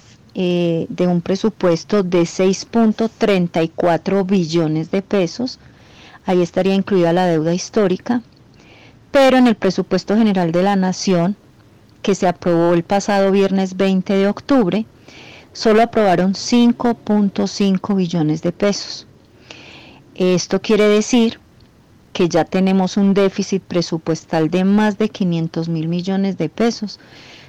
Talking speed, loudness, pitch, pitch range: 120 wpm, -17 LUFS, 190 Hz, 175-205 Hz